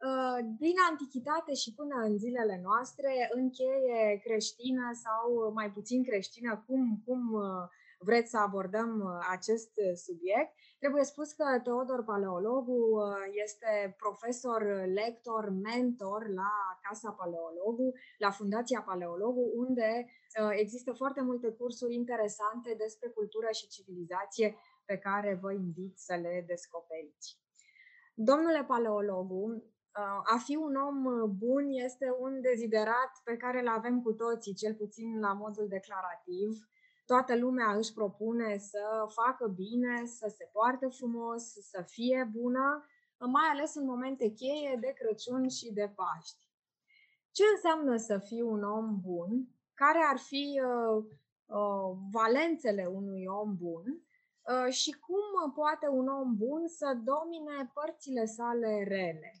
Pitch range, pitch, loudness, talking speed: 205-260 Hz, 230 Hz, -34 LUFS, 125 wpm